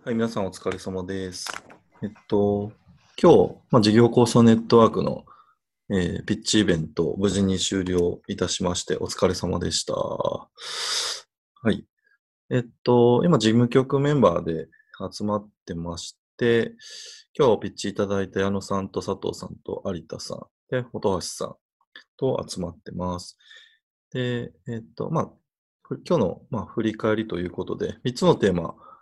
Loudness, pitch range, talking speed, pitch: -24 LUFS, 95-125 Hz, 290 characters per minute, 110 Hz